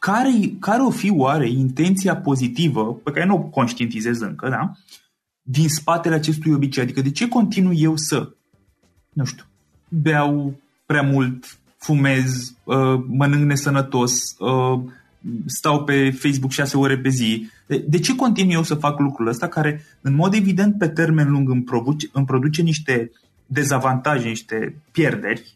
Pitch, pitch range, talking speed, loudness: 145 Hz, 130-165 Hz, 145 wpm, -20 LUFS